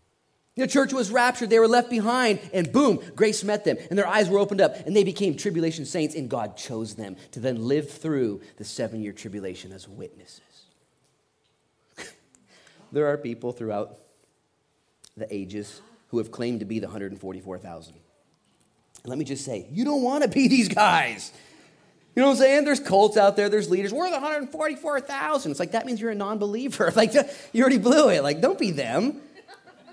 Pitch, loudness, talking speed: 200 Hz, -23 LUFS, 185 wpm